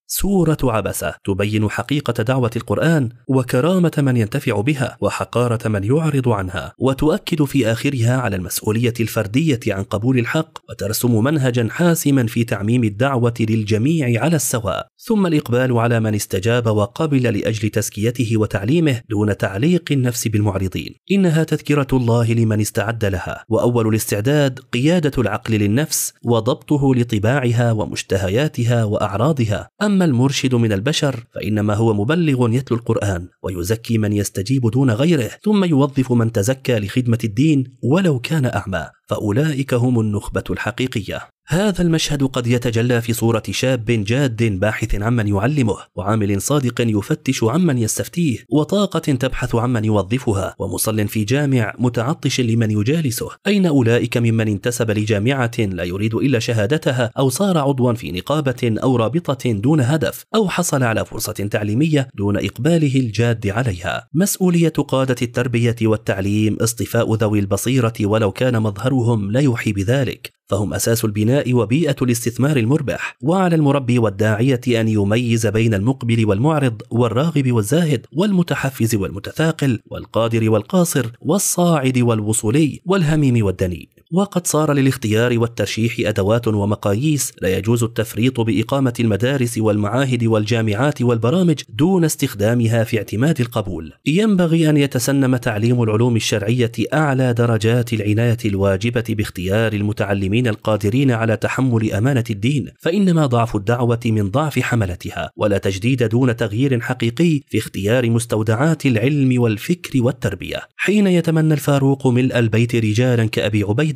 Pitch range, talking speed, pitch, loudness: 110-140 Hz, 125 wpm, 120 Hz, -18 LUFS